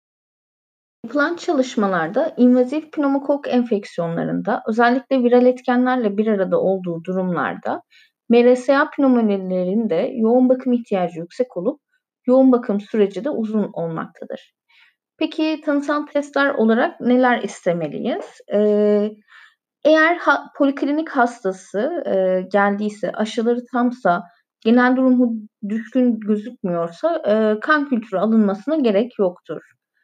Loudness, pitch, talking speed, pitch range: -19 LUFS, 240 Hz, 90 wpm, 205-270 Hz